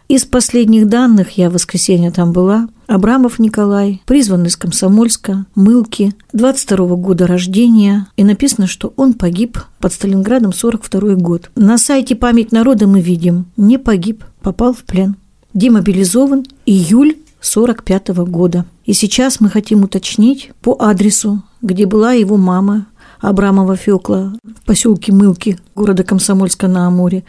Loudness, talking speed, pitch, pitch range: -11 LUFS, 135 wpm, 205 Hz, 190-230 Hz